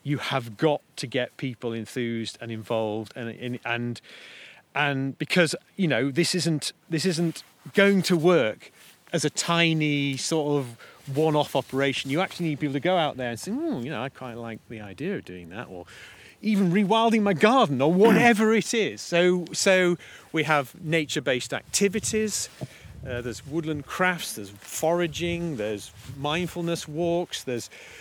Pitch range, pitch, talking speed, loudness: 125-175 Hz, 150 Hz, 165 wpm, -25 LUFS